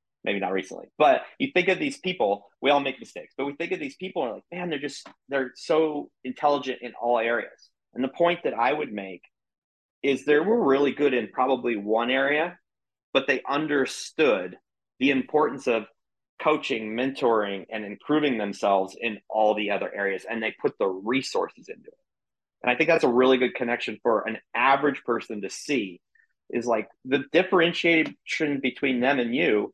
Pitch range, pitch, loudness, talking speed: 120-155 Hz, 135 Hz, -25 LUFS, 185 wpm